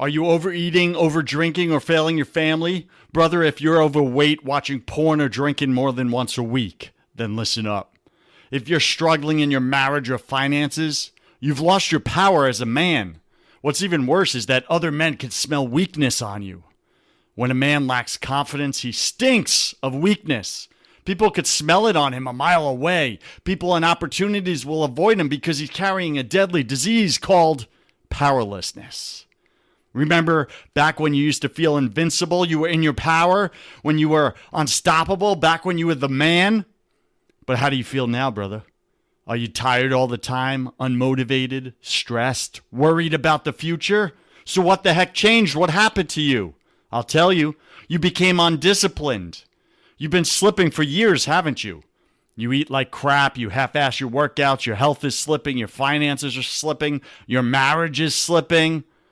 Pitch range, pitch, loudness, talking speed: 130-170 Hz, 150 Hz, -19 LUFS, 170 wpm